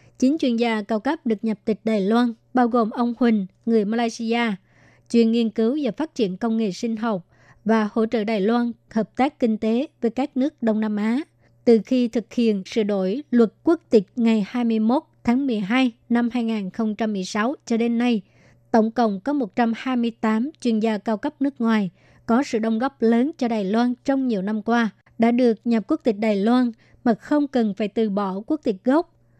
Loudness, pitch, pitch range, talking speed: -22 LUFS, 230 Hz, 220-245 Hz, 200 wpm